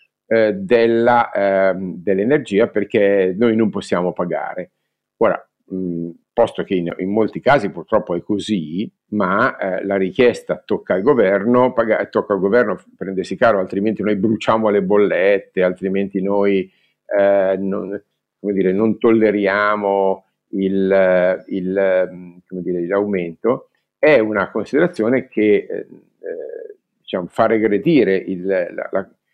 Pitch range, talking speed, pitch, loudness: 95-110 Hz, 125 wpm, 100 Hz, -17 LUFS